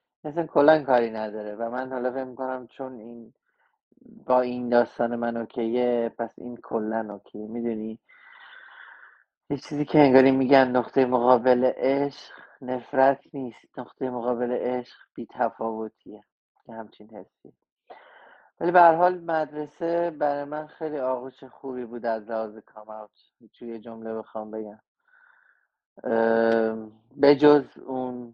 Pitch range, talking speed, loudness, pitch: 115-145 Hz, 125 wpm, -24 LUFS, 125 Hz